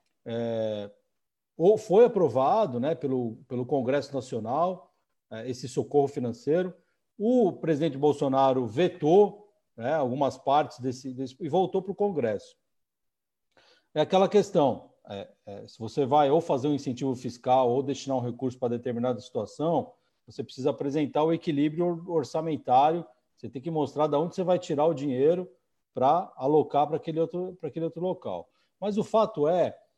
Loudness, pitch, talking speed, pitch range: -27 LUFS, 150 Hz, 150 wpm, 130-175 Hz